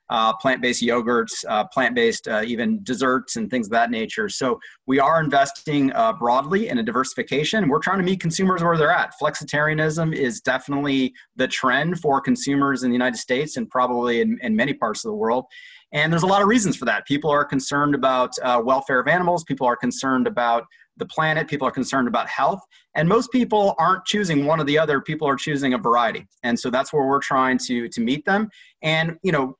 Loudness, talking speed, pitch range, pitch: -21 LUFS, 210 wpm, 130-195 Hz, 150 Hz